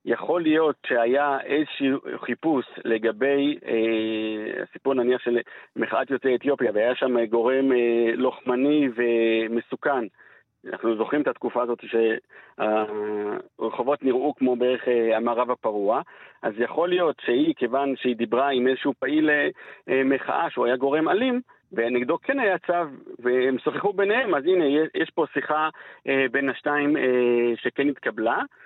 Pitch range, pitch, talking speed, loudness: 120-145 Hz, 130 Hz, 140 wpm, -24 LUFS